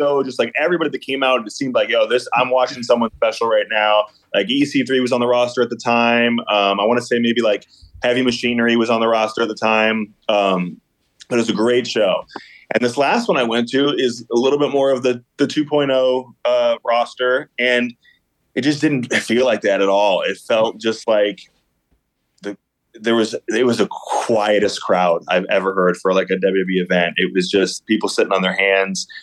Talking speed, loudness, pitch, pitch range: 215 wpm, -17 LUFS, 120 Hz, 105-130 Hz